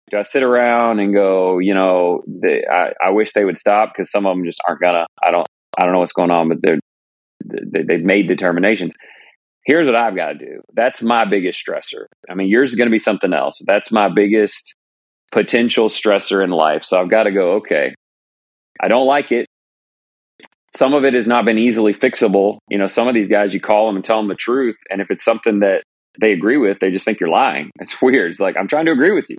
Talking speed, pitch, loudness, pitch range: 235 wpm, 100 Hz, -15 LUFS, 90-110 Hz